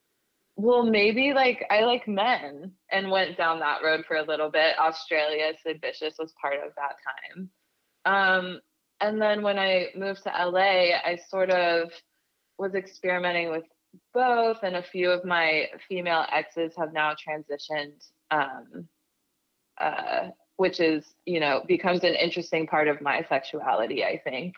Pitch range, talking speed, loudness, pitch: 160-195 Hz, 155 wpm, -26 LUFS, 175 Hz